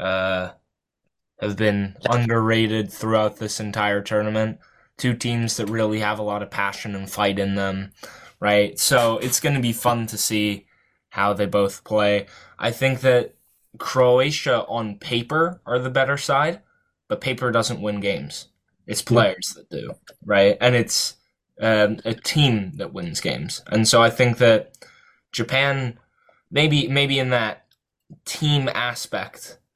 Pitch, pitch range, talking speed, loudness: 115 Hz, 105-130 Hz, 145 wpm, -21 LUFS